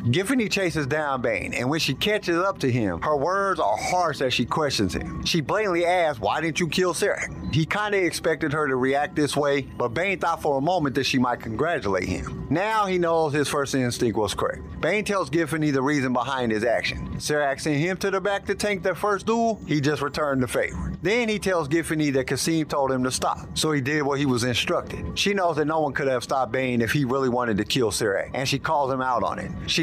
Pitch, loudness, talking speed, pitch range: 150 Hz, -24 LUFS, 235 wpm, 135-180 Hz